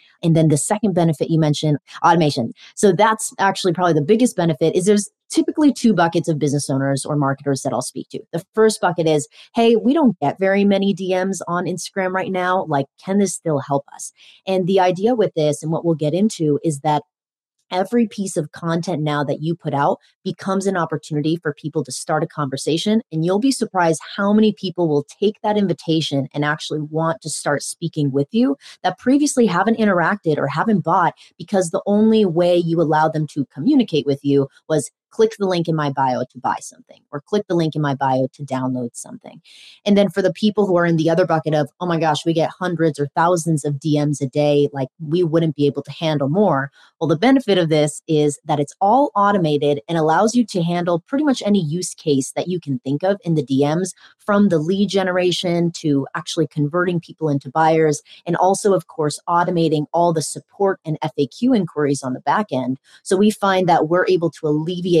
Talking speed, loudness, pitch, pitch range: 210 wpm, -19 LUFS, 165 Hz, 150-195 Hz